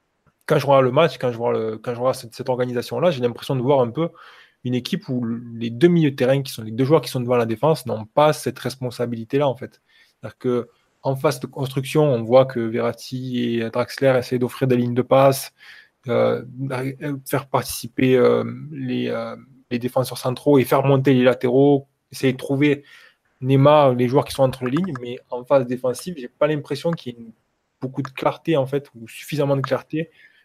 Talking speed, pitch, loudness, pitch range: 210 wpm, 130 Hz, -21 LUFS, 125-140 Hz